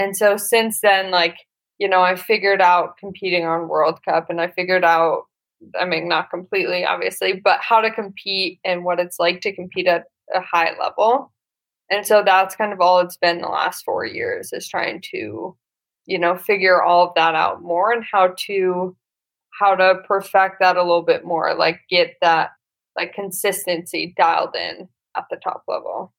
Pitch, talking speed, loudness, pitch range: 185 Hz, 190 wpm, -19 LUFS, 175-210 Hz